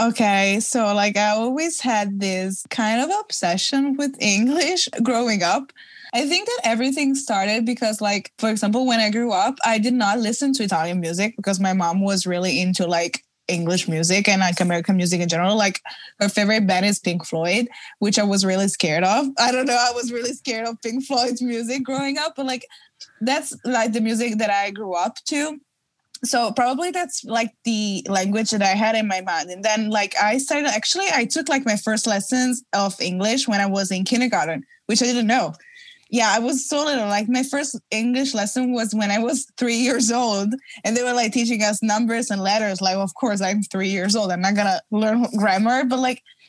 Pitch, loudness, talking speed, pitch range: 225 Hz, -21 LUFS, 210 wpm, 200-250 Hz